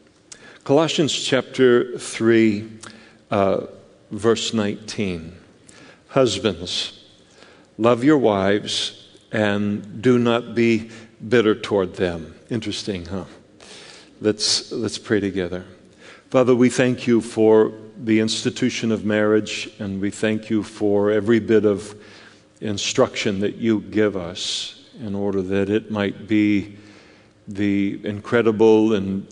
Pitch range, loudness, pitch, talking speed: 100-115 Hz, -20 LUFS, 105 Hz, 110 wpm